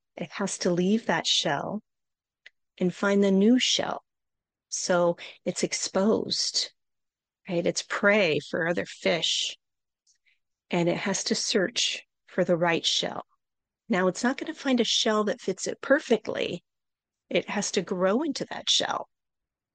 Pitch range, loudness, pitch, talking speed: 185-240 Hz, -26 LUFS, 200 Hz, 145 wpm